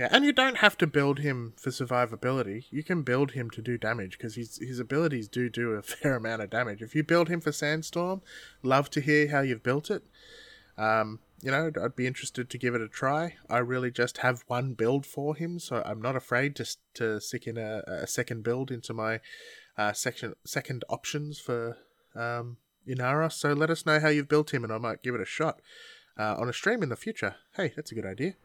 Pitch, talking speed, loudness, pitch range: 125 Hz, 225 wpm, -30 LUFS, 115-150 Hz